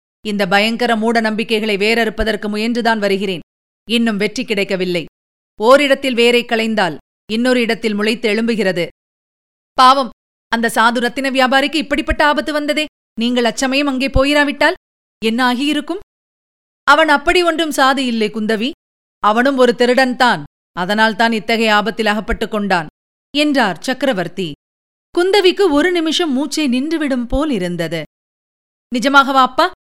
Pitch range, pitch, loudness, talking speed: 220-280 Hz, 240 Hz, -15 LUFS, 115 wpm